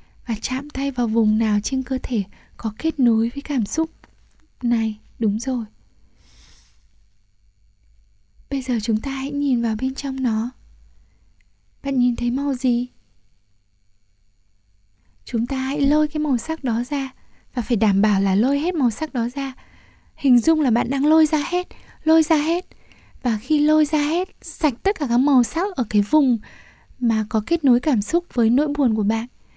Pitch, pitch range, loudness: 250 Hz, 220-285 Hz, -21 LUFS